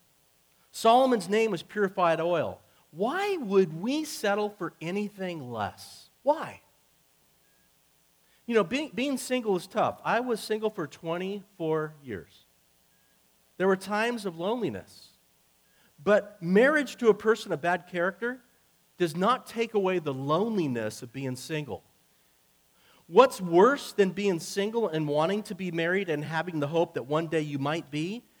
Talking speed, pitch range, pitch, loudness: 145 wpm, 145-215 Hz, 180 Hz, -28 LUFS